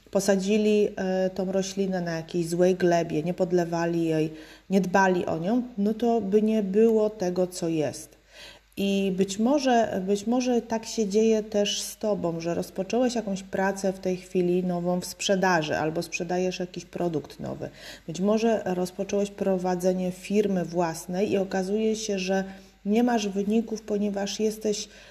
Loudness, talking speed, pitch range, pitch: -26 LUFS, 150 wpm, 180-210 Hz, 195 Hz